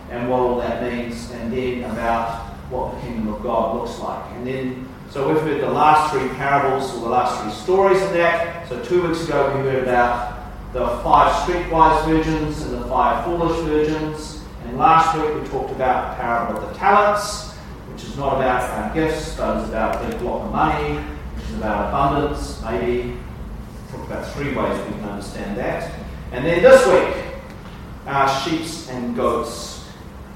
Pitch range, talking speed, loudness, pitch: 120-160 Hz, 185 wpm, -20 LUFS, 130 Hz